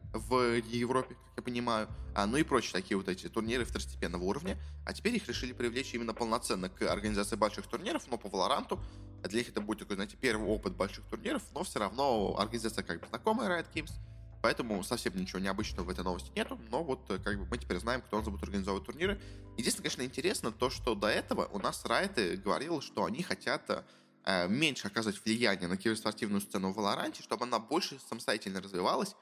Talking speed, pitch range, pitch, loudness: 195 wpm, 100-120 Hz, 110 Hz, -35 LUFS